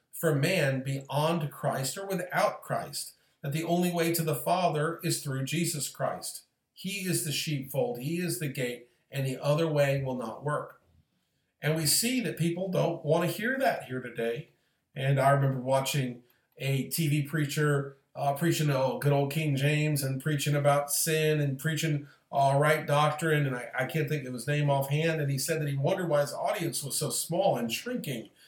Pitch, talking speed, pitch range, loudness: 150 Hz, 195 wpm, 135-160 Hz, -29 LUFS